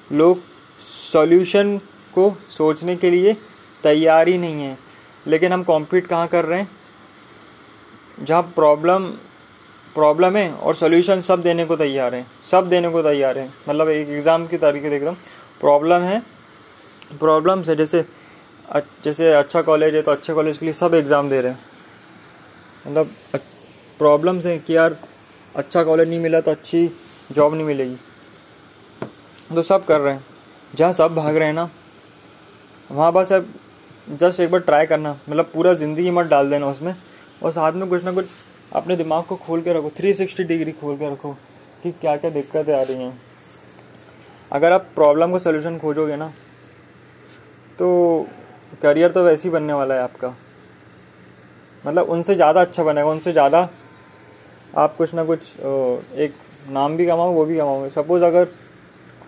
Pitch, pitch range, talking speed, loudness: 160 Hz, 145-175 Hz, 165 wpm, -18 LUFS